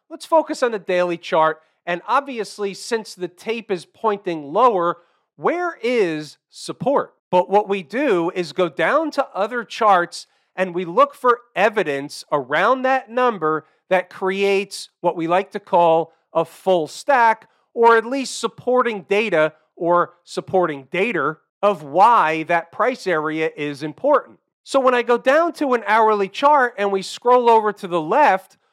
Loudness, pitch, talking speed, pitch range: -19 LUFS, 195 Hz, 160 wpm, 175-240 Hz